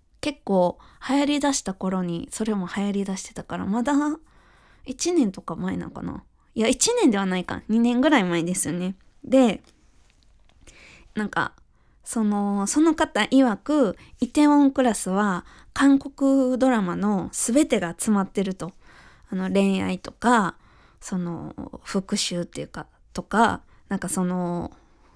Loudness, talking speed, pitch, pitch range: -23 LUFS, 255 characters per minute, 205 Hz, 185-265 Hz